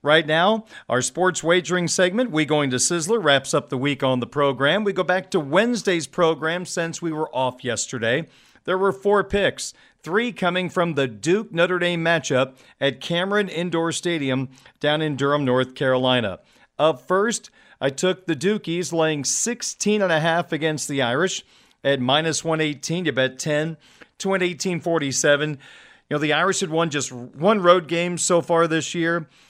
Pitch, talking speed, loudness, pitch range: 165 Hz, 165 wpm, -21 LUFS, 145-185 Hz